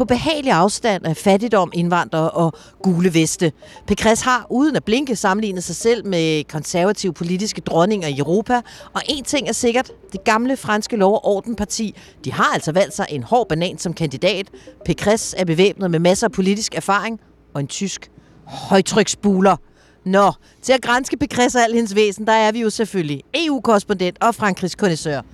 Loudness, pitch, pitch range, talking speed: -18 LUFS, 195 Hz, 175-225 Hz, 175 wpm